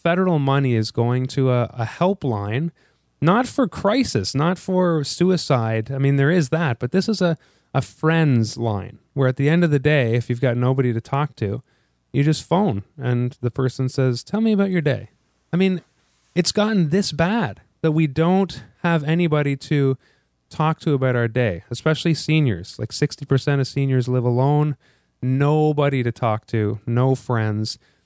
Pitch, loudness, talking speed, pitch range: 140 Hz, -21 LUFS, 180 wpm, 120-165 Hz